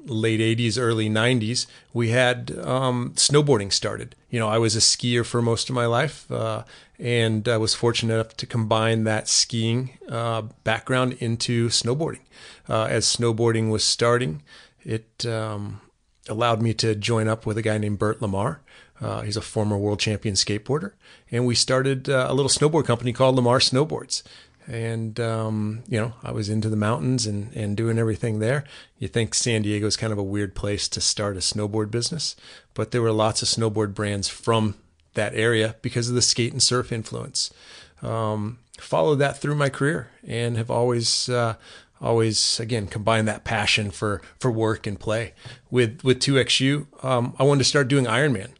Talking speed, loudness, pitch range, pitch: 185 wpm, -23 LUFS, 110-125 Hz, 115 Hz